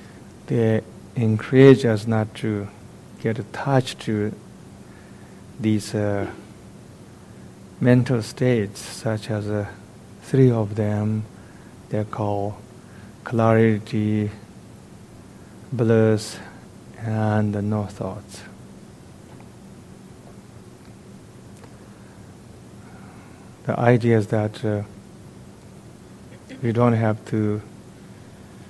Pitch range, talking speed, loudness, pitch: 105-115 Hz, 75 wpm, -22 LUFS, 110 Hz